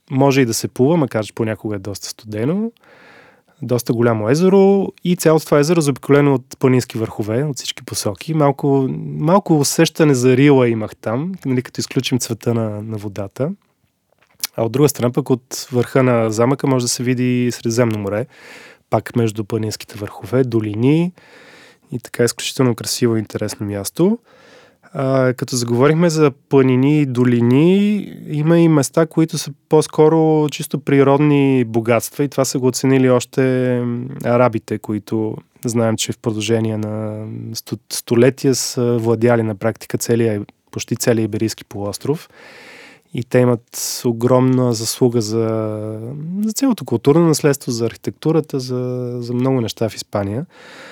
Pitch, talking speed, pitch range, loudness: 125 Hz, 145 wpm, 115-145 Hz, -17 LUFS